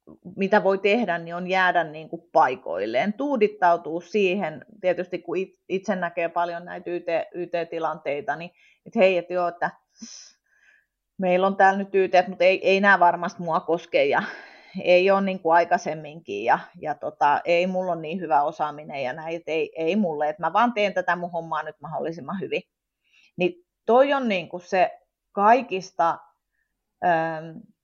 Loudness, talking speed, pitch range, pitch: -23 LUFS, 155 wpm, 170-195 Hz, 180 Hz